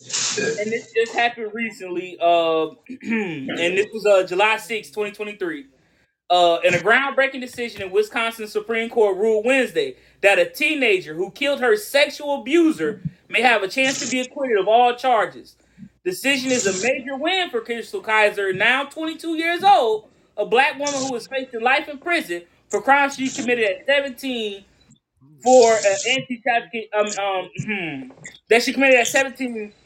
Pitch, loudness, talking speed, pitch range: 235 Hz, -20 LUFS, 160 wpm, 210-275 Hz